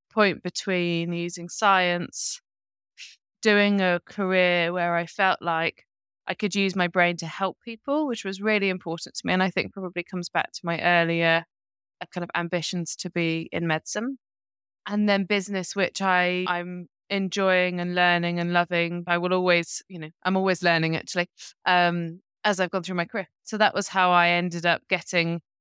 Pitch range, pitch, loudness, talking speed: 170-190 Hz, 180 Hz, -24 LUFS, 180 wpm